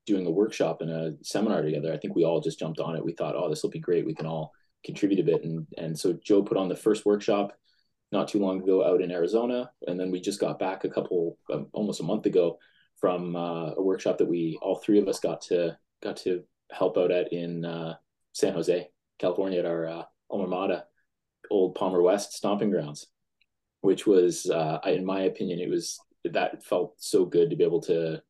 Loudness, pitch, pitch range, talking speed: -28 LUFS, 90 Hz, 80-105 Hz, 225 wpm